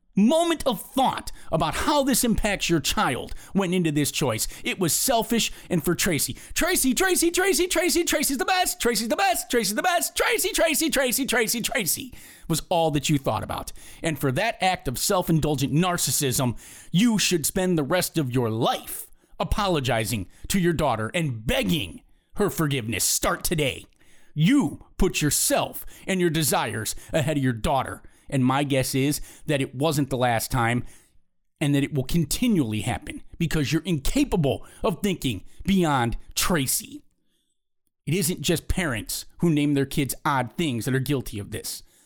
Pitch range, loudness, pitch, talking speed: 135-225 Hz, -24 LUFS, 165 Hz, 170 wpm